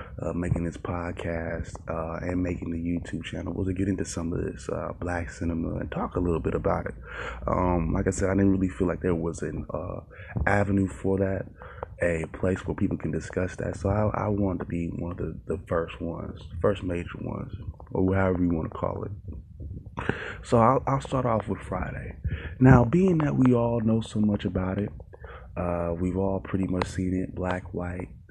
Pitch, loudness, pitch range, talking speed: 95 Hz, -28 LUFS, 85-100 Hz, 210 wpm